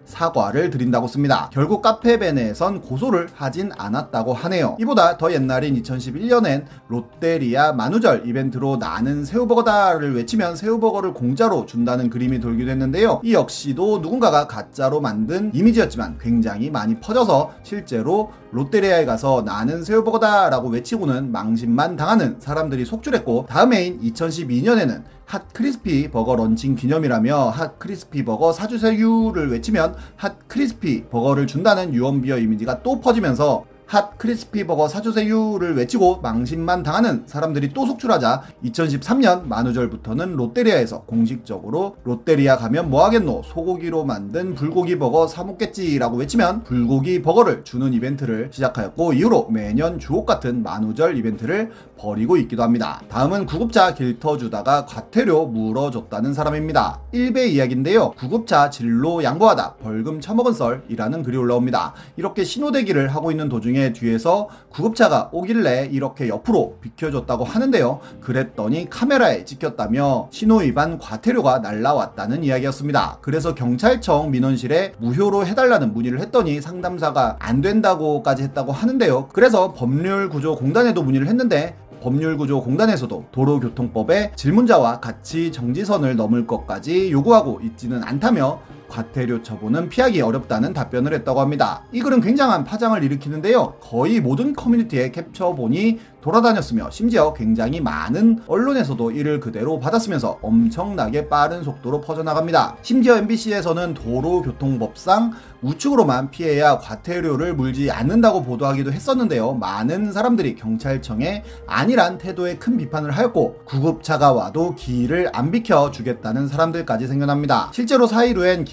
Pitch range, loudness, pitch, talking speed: 125-215 Hz, -19 LUFS, 155 Hz, 375 characters per minute